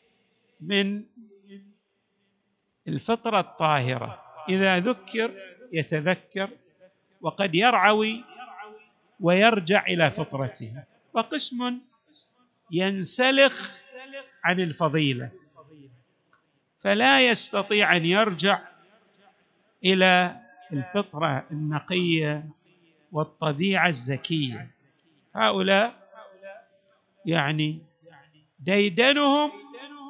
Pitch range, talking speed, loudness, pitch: 160-220 Hz, 55 wpm, -23 LUFS, 190 Hz